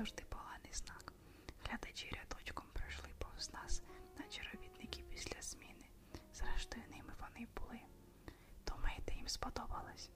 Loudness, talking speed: -50 LUFS, 110 wpm